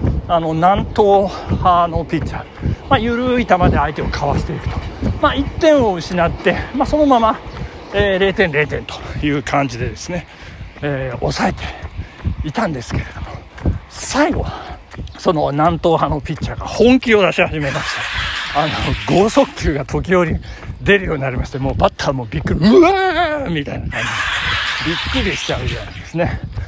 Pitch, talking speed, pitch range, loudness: 180 Hz, 325 characters per minute, 150-230 Hz, -17 LUFS